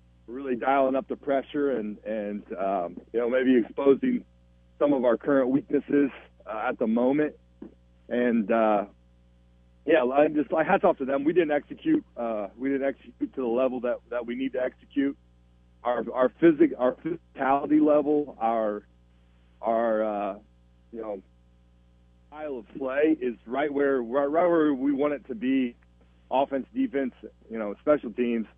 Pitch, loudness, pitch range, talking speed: 125 Hz, -26 LUFS, 100-140 Hz, 160 wpm